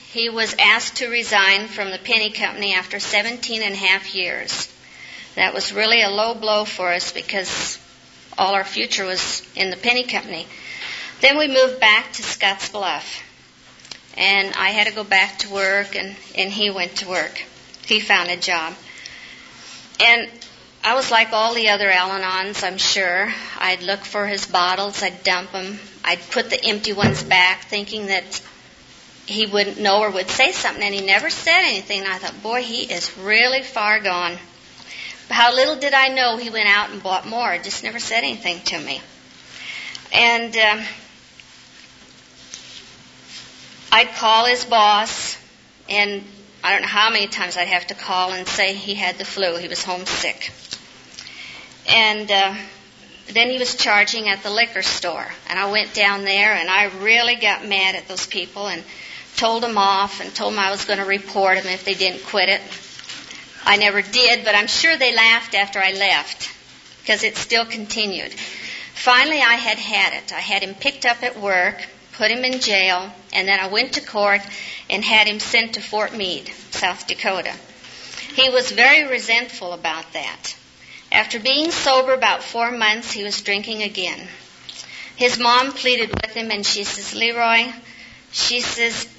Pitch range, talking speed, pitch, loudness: 190-230 Hz, 175 wpm, 205 Hz, -18 LUFS